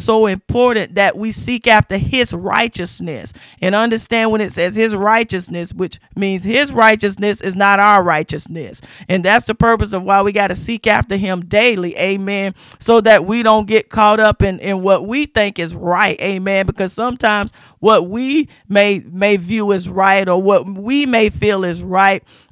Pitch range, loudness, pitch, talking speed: 185-220 Hz, -14 LUFS, 200 Hz, 180 wpm